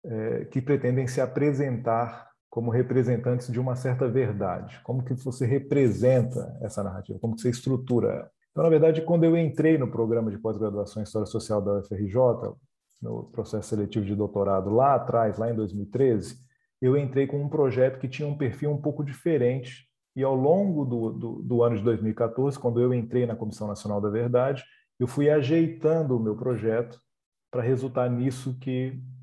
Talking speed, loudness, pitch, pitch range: 175 wpm, -26 LUFS, 125 Hz, 115-135 Hz